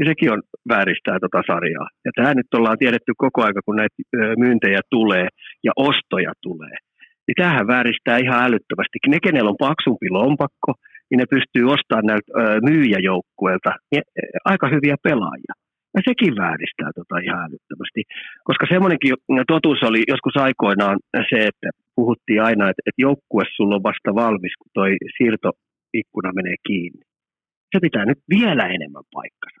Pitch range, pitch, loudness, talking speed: 105-135 Hz, 120 Hz, -18 LUFS, 150 wpm